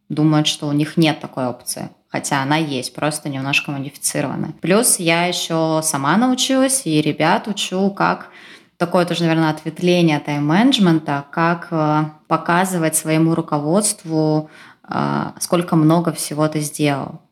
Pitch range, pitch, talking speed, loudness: 150-175 Hz, 160 Hz, 125 wpm, -18 LUFS